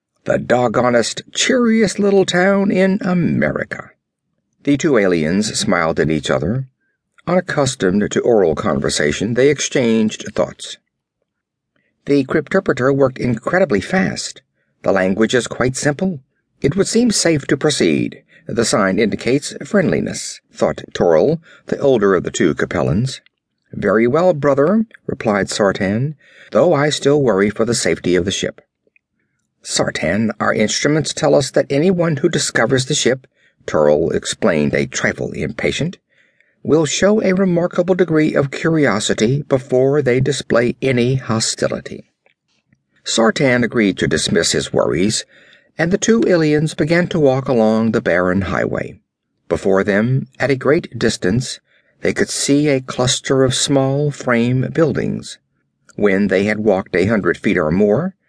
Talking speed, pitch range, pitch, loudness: 135 wpm, 115-165 Hz, 135 Hz, -16 LUFS